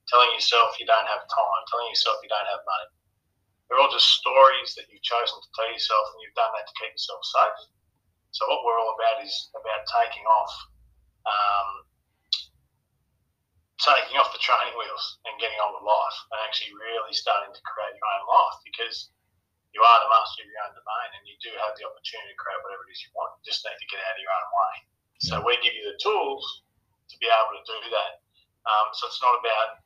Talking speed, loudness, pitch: 215 wpm, -24 LUFS, 115 Hz